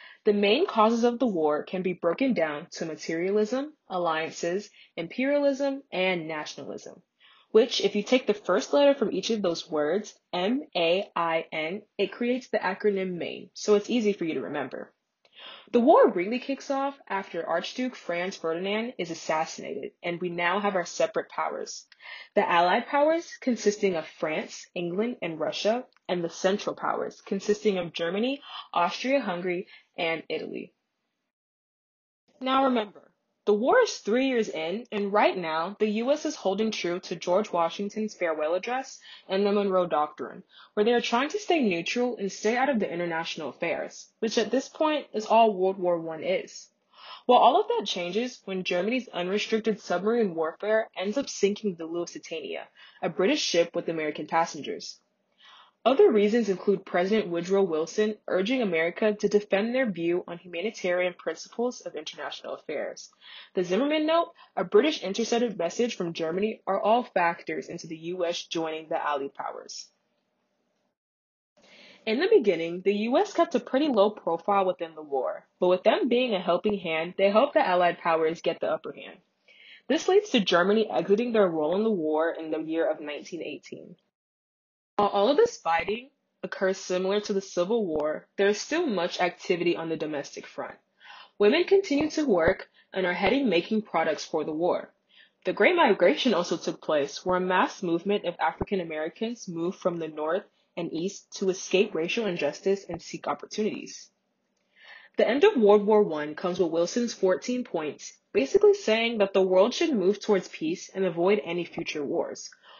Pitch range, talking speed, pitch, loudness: 170-235 Hz, 165 wpm, 195 Hz, -27 LUFS